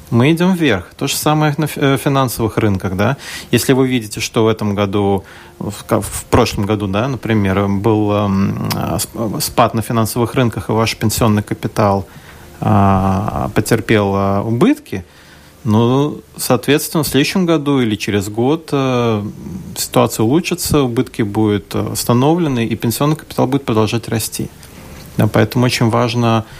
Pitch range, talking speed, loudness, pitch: 105-135 Hz, 125 wpm, -15 LUFS, 115 Hz